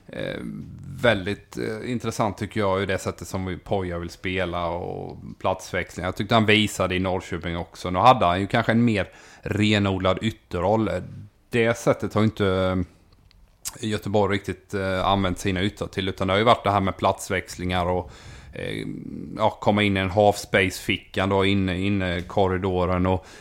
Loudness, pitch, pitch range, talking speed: -24 LUFS, 95 Hz, 90-105 Hz, 155 wpm